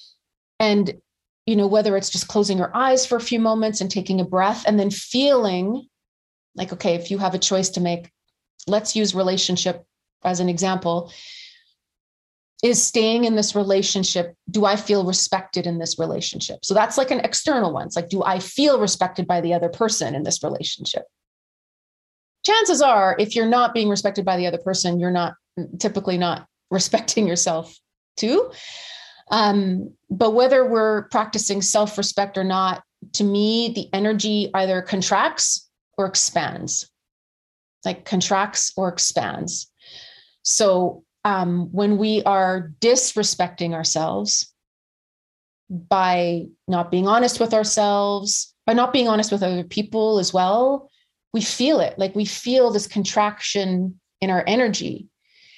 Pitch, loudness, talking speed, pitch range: 200 Hz, -20 LUFS, 150 wpm, 180-220 Hz